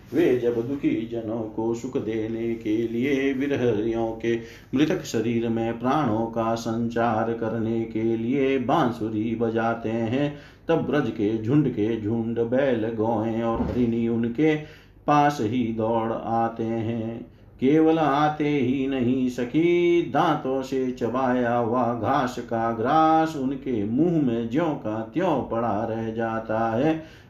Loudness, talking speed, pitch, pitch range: -24 LUFS, 135 wpm, 115 Hz, 115-135 Hz